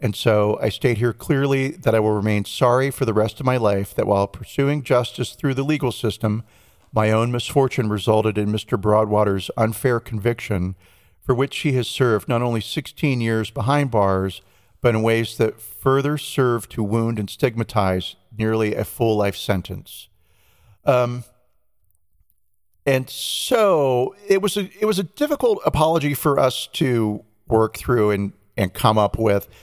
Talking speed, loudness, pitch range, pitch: 165 wpm, -21 LUFS, 105-130 Hz, 110 Hz